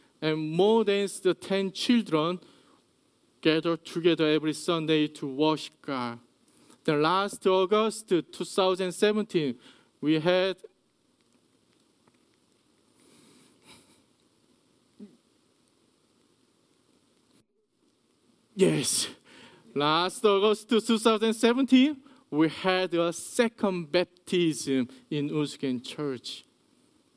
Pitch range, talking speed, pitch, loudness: 155-210 Hz, 70 wpm, 180 Hz, -27 LUFS